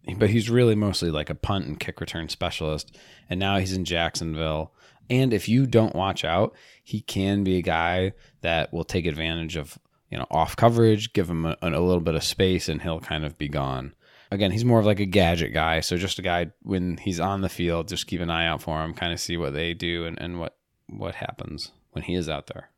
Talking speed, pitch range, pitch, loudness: 235 wpm, 80-100 Hz, 85 Hz, -25 LUFS